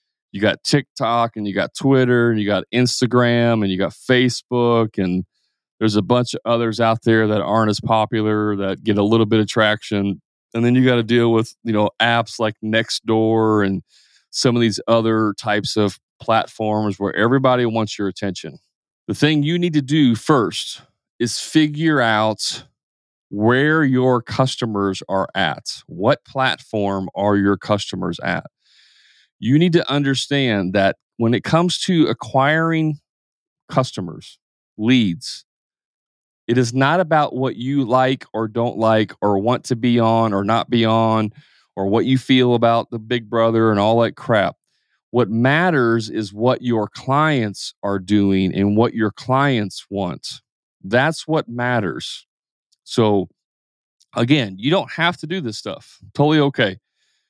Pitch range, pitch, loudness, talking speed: 105-130 Hz, 115 Hz, -18 LUFS, 155 wpm